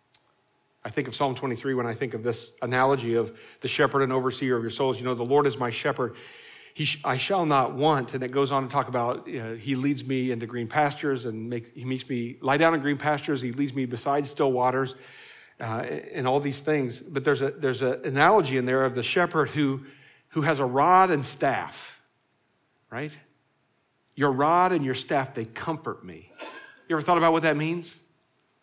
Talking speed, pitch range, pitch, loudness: 215 wpm, 125-150 Hz, 135 Hz, -26 LUFS